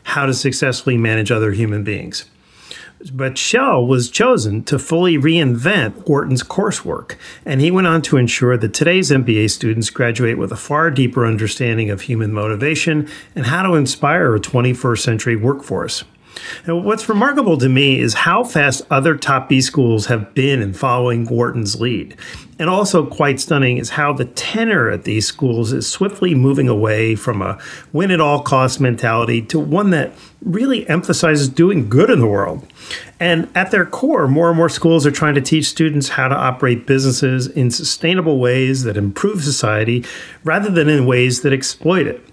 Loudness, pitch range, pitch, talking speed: -15 LUFS, 120-160 Hz, 135 Hz, 175 wpm